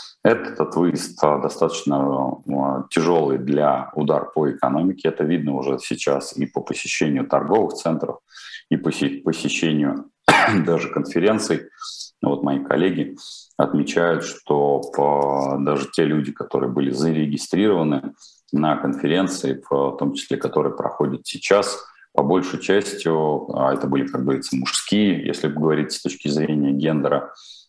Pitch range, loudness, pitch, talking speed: 70-75 Hz, -21 LUFS, 70 Hz, 120 wpm